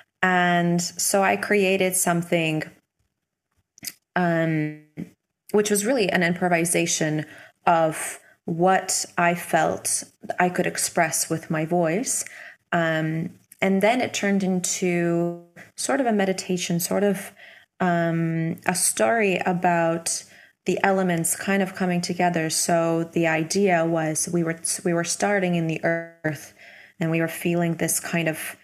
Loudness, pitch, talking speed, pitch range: -23 LUFS, 175 Hz, 130 wpm, 165-185 Hz